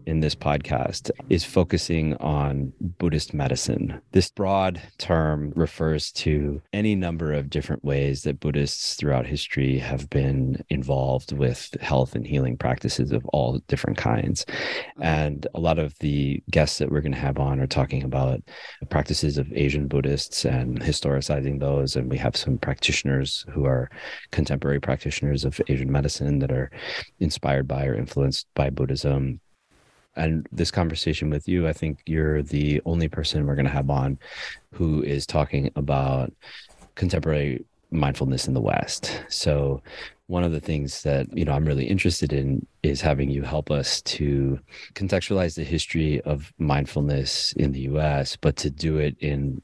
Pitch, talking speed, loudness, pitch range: 70 Hz, 160 wpm, -25 LUFS, 70-80 Hz